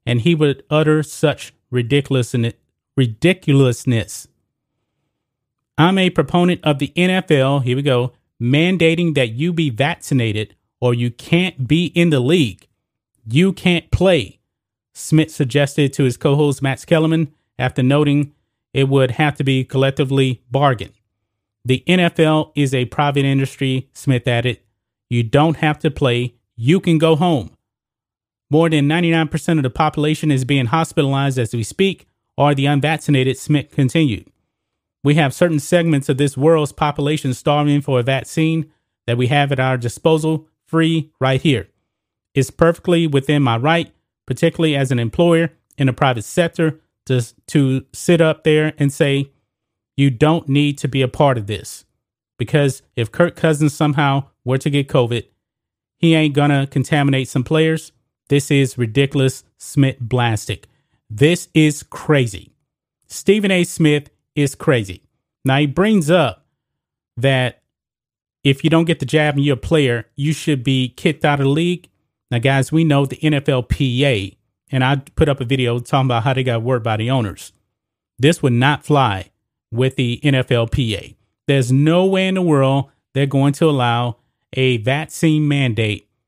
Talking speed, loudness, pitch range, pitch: 155 wpm, -17 LUFS, 125-155 Hz, 140 Hz